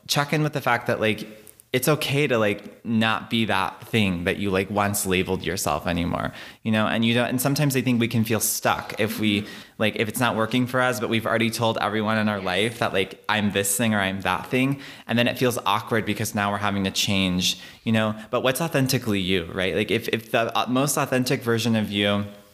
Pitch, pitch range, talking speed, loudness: 110 Hz, 100-120 Hz, 235 wpm, -23 LUFS